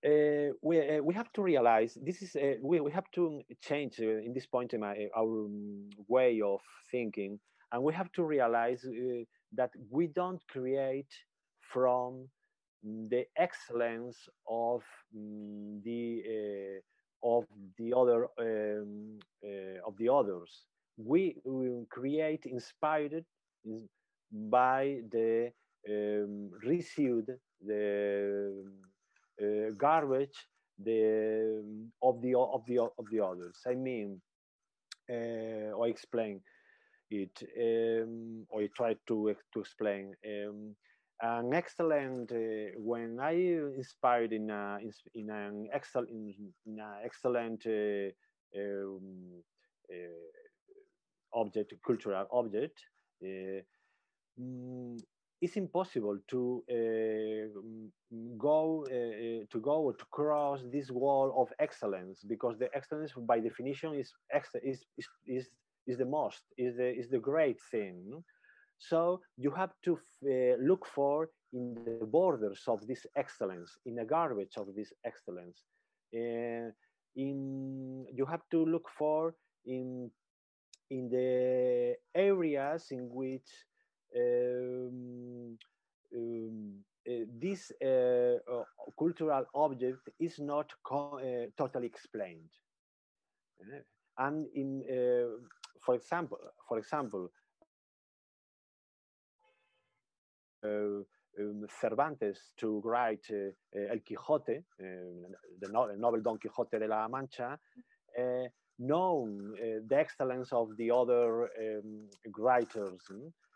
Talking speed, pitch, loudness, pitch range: 115 wpm, 120 Hz, -35 LUFS, 110-140 Hz